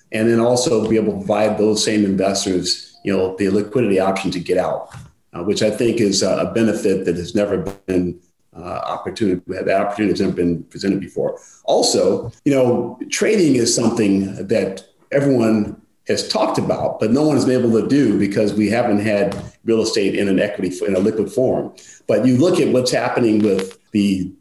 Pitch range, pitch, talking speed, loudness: 95-110 Hz, 105 Hz, 190 wpm, -18 LUFS